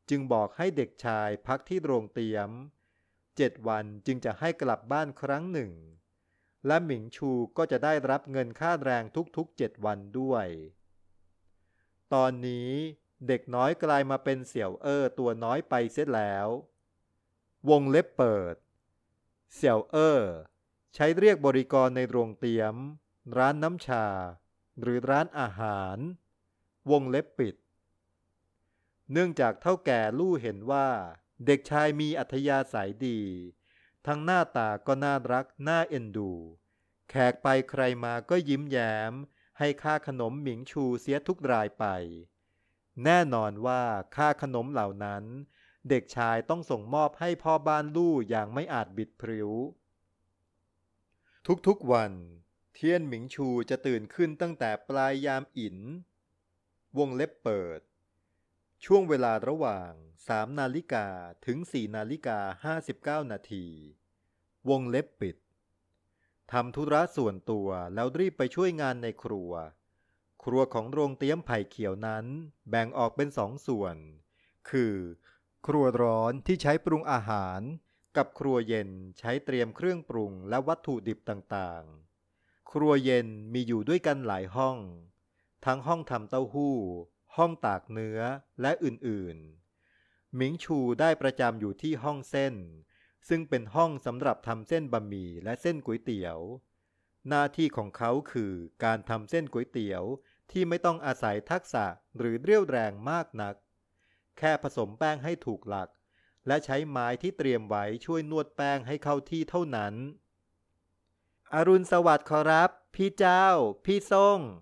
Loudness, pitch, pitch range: -30 LUFS, 120 Hz, 100-145 Hz